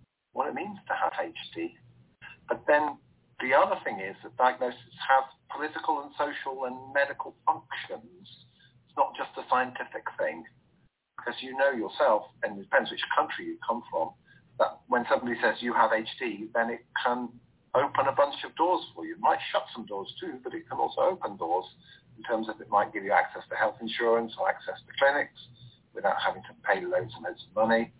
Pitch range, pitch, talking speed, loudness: 115-145 Hz, 125 Hz, 195 wpm, -29 LUFS